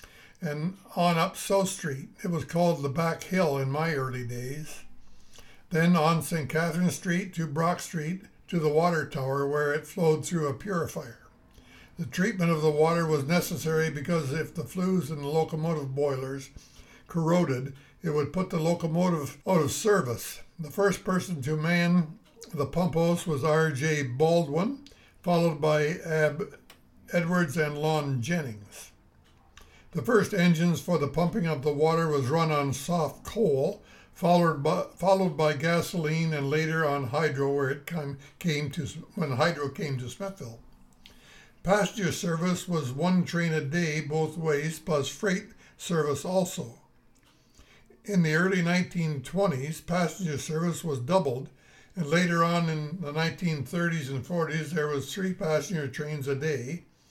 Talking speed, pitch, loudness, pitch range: 150 wpm, 160 Hz, -28 LUFS, 145-175 Hz